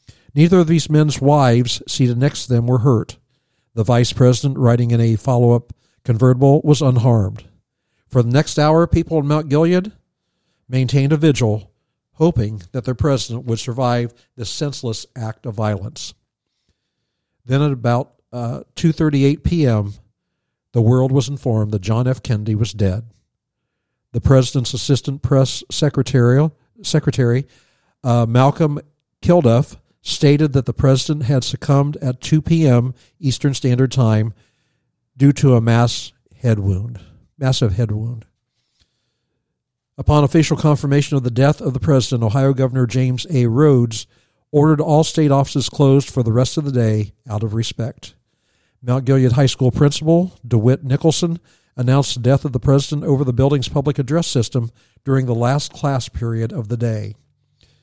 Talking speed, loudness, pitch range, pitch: 150 wpm, -17 LUFS, 120-145 Hz, 130 Hz